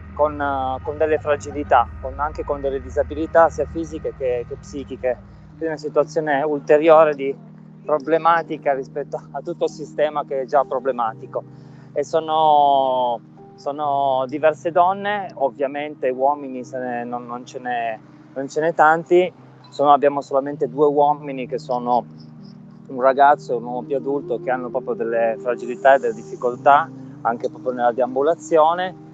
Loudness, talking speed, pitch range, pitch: -20 LUFS, 145 wpm, 130-155 Hz, 145 Hz